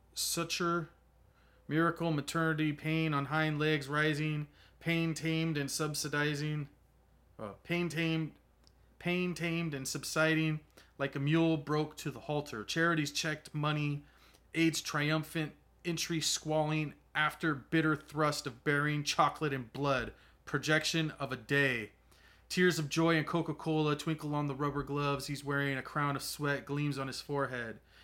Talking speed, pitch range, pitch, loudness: 140 wpm, 140-160 Hz, 150 Hz, -33 LUFS